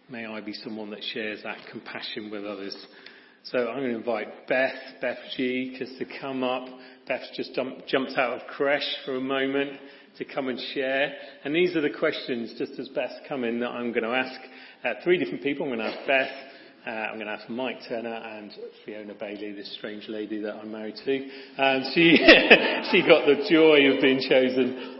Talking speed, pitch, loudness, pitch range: 205 wpm, 130 Hz, -24 LUFS, 110-135 Hz